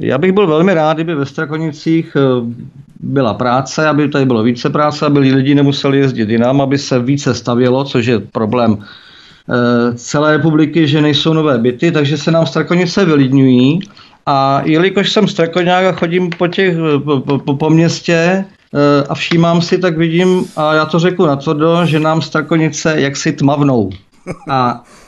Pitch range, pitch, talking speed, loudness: 135-165 Hz, 150 Hz, 160 wpm, -12 LUFS